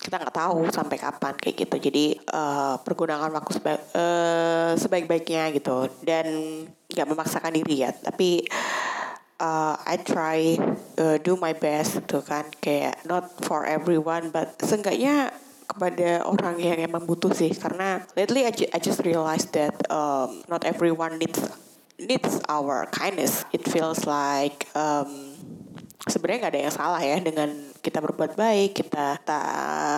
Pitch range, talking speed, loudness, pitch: 150-175 Hz, 145 wpm, -25 LUFS, 165 Hz